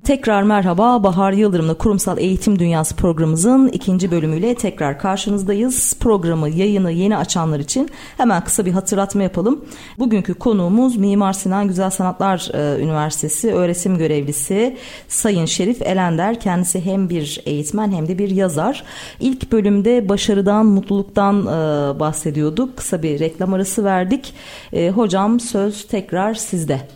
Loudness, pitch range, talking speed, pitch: -17 LUFS, 175-215 Hz, 125 wpm, 195 Hz